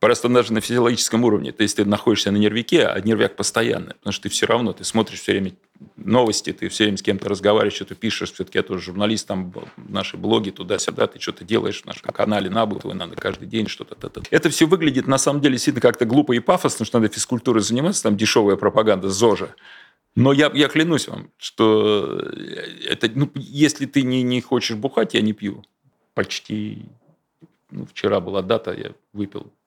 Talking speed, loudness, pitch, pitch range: 195 wpm, -20 LUFS, 115 Hz, 105-135 Hz